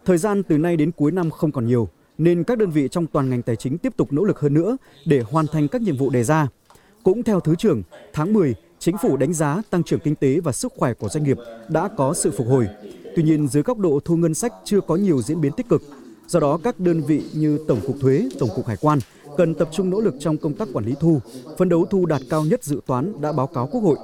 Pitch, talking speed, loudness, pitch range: 155 Hz, 275 wpm, -21 LUFS, 135-175 Hz